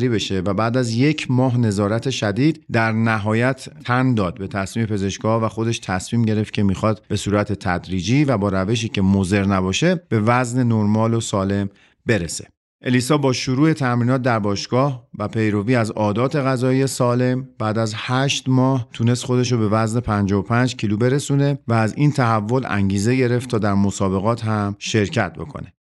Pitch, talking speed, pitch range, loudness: 115 Hz, 165 wpm, 105-130 Hz, -19 LUFS